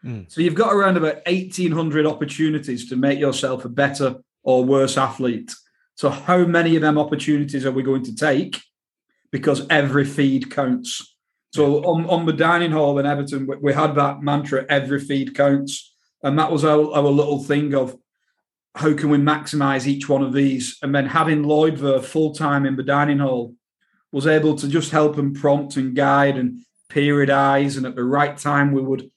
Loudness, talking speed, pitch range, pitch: -19 LUFS, 185 wpm, 135-155 Hz, 145 Hz